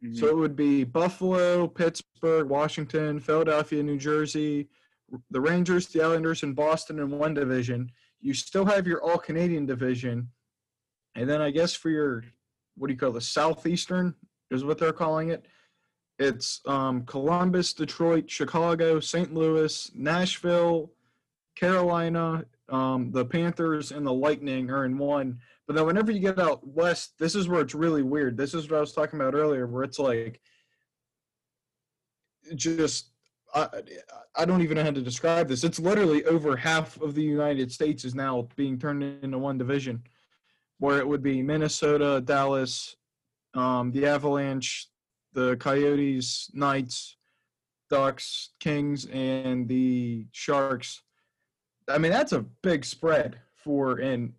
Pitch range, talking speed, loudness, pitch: 130-165 Hz, 150 wpm, -27 LUFS, 150 Hz